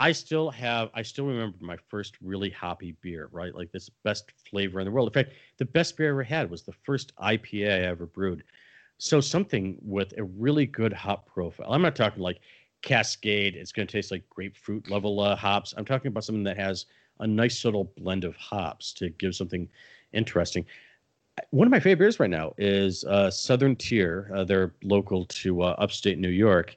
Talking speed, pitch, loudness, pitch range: 205 wpm, 100 Hz, -27 LUFS, 95-120 Hz